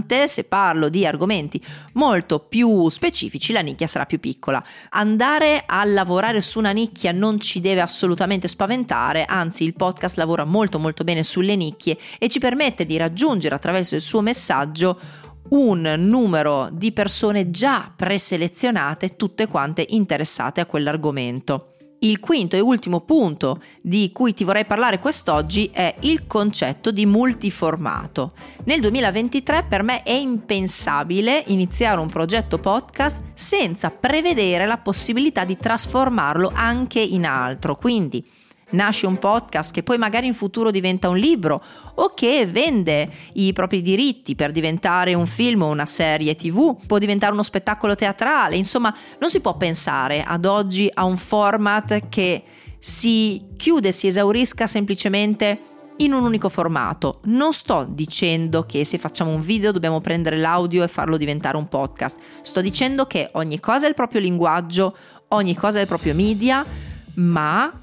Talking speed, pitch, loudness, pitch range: 150 wpm, 195 Hz, -19 LUFS, 165-225 Hz